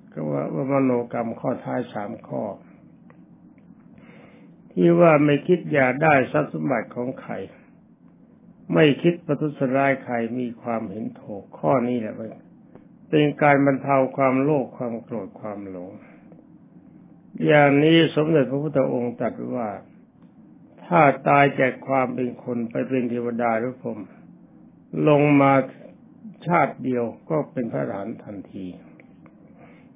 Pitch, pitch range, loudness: 135 Hz, 120-150 Hz, -21 LUFS